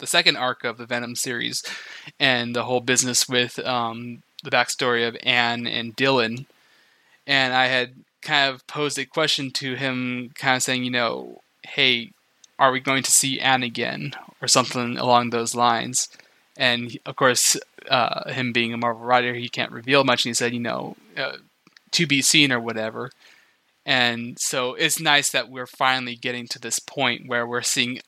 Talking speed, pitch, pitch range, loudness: 185 wpm, 125 Hz, 120-135 Hz, -21 LUFS